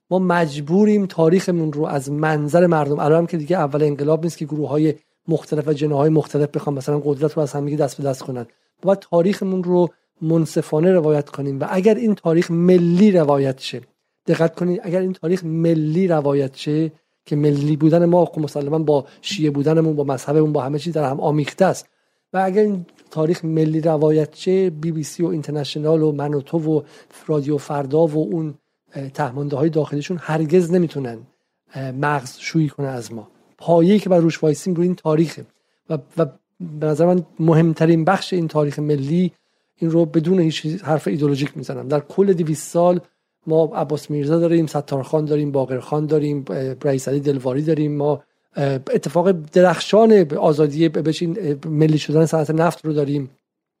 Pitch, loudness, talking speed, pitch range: 155 Hz, -19 LUFS, 170 wpm, 145-170 Hz